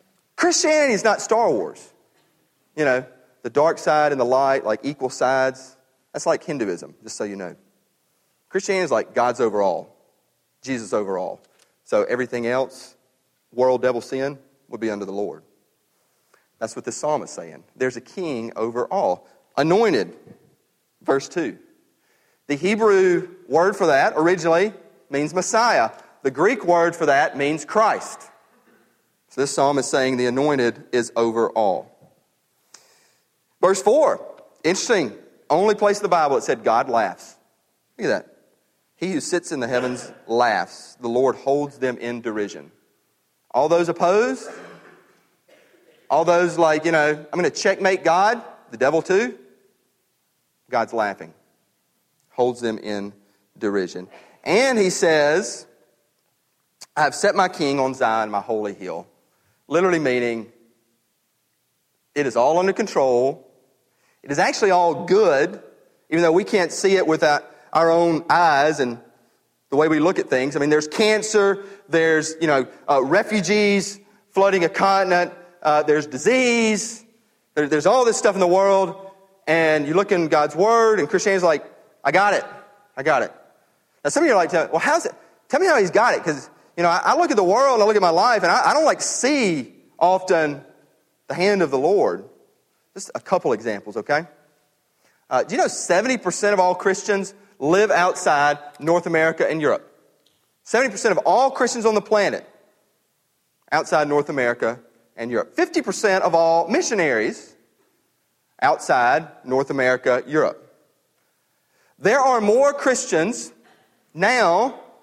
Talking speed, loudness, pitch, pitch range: 150 wpm, -20 LUFS, 155 Hz, 130-195 Hz